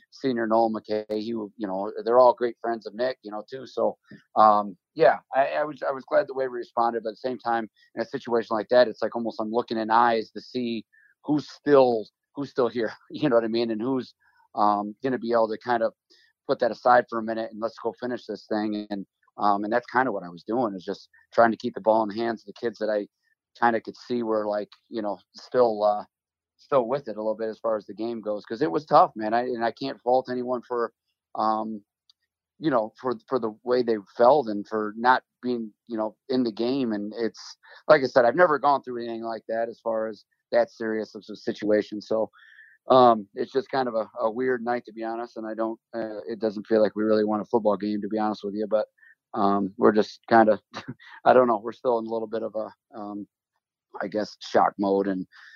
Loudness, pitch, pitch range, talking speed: -25 LUFS, 115 Hz, 105-120 Hz, 250 wpm